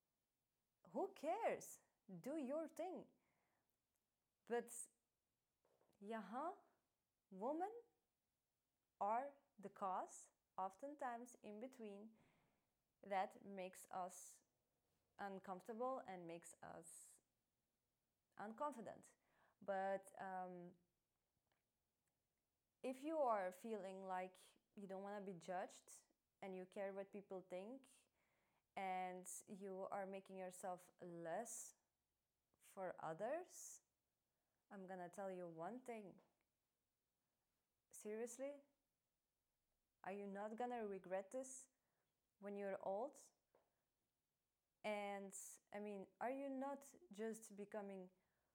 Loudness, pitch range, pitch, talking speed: -52 LUFS, 190-245 Hz, 200 Hz, 90 wpm